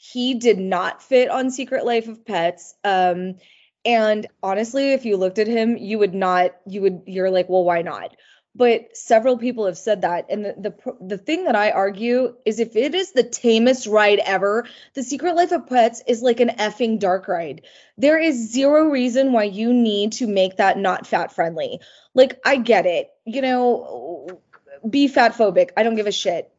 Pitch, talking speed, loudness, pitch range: 225 Hz, 195 wpm, -19 LUFS, 200-255 Hz